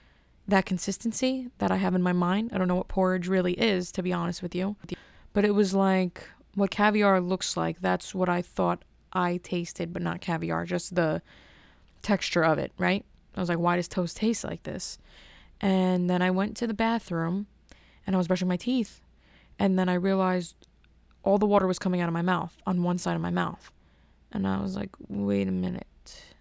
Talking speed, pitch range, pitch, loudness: 205 wpm, 170-195 Hz, 180 Hz, -28 LUFS